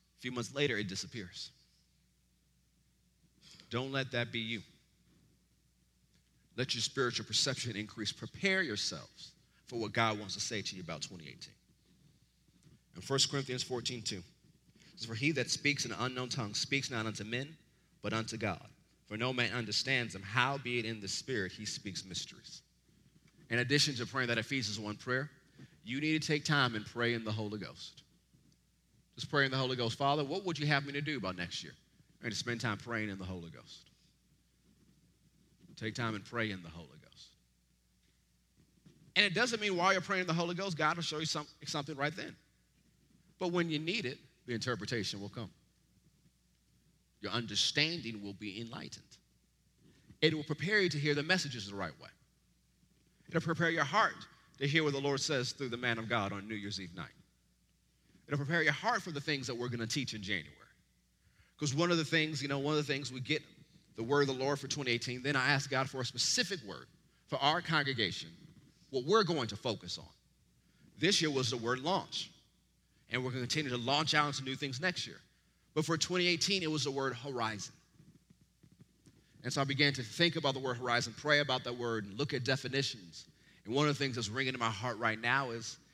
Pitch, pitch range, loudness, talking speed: 130 Hz, 110-150 Hz, -34 LUFS, 200 wpm